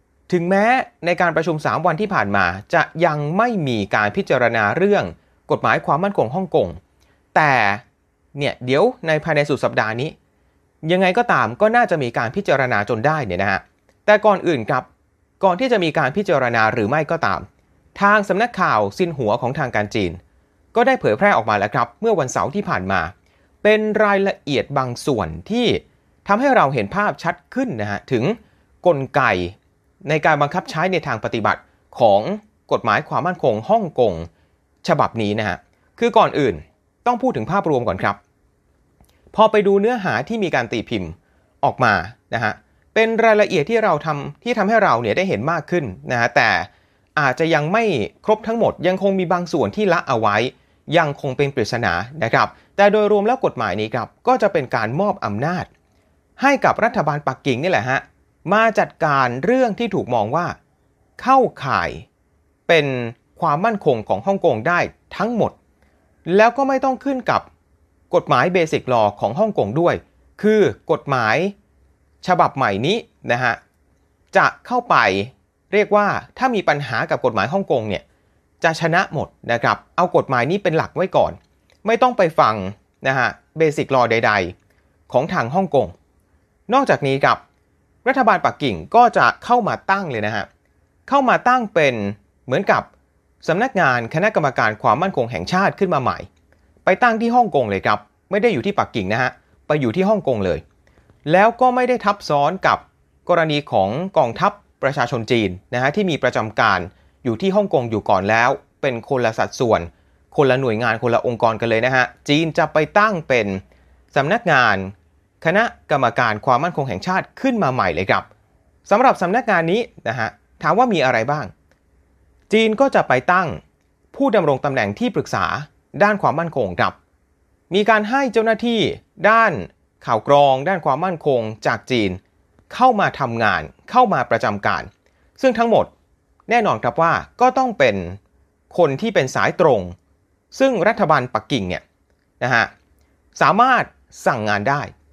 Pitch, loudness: 155 Hz, -18 LUFS